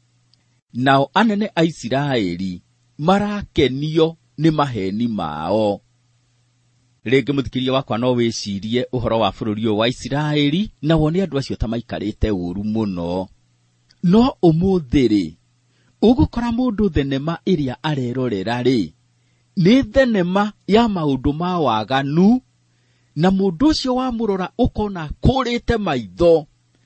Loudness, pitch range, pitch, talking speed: -19 LUFS, 120-180 Hz, 135 Hz, 105 wpm